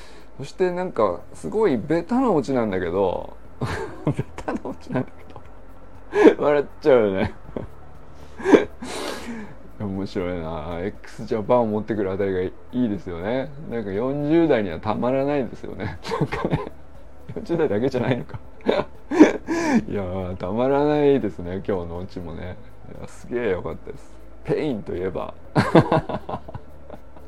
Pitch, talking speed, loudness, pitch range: 105 Hz, 275 characters per minute, -23 LUFS, 90-135 Hz